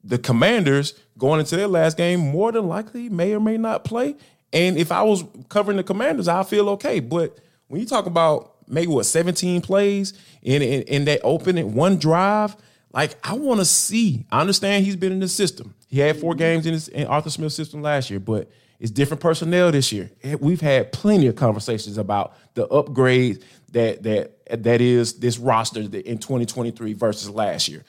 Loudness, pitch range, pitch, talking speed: -21 LUFS, 125-190 Hz, 155 Hz, 200 wpm